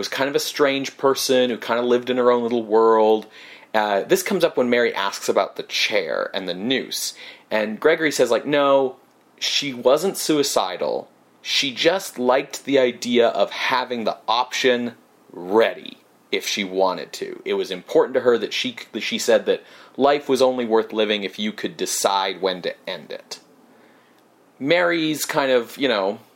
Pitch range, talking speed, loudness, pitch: 115-170 Hz, 180 wpm, -21 LUFS, 130 Hz